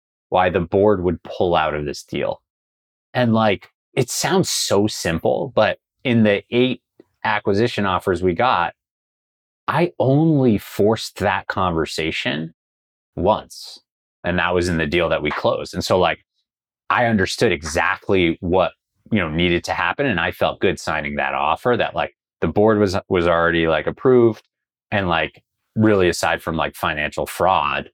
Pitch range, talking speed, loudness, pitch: 80-105 Hz, 160 wpm, -19 LUFS, 90 Hz